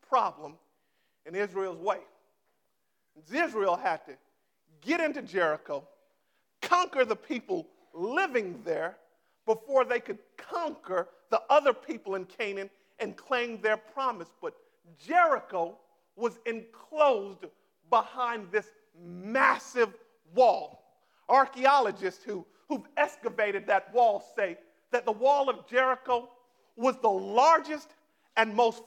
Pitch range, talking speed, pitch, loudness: 205-295 Hz, 110 wpm, 245 Hz, -29 LUFS